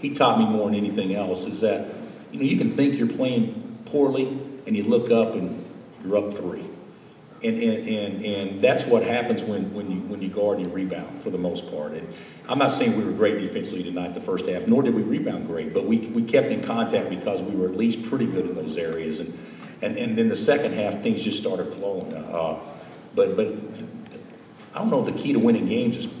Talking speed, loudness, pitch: 235 wpm, -24 LUFS, 115 Hz